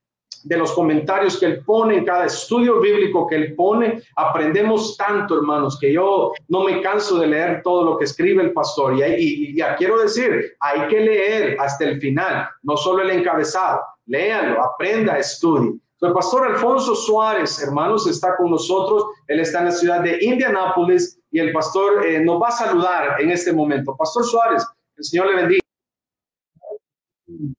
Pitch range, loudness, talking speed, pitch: 160-225 Hz, -18 LUFS, 175 wpm, 185 Hz